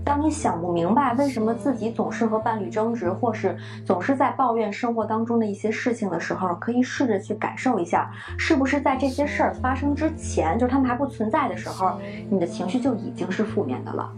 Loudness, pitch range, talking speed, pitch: -24 LUFS, 220-275 Hz, 345 characters per minute, 235 Hz